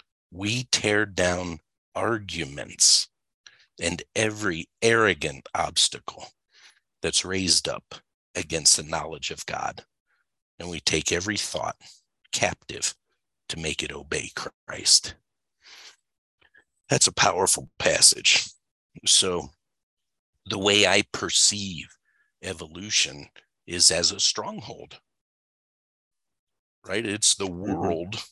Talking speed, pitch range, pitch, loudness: 95 wpm, 90-105 Hz, 100 Hz, -22 LUFS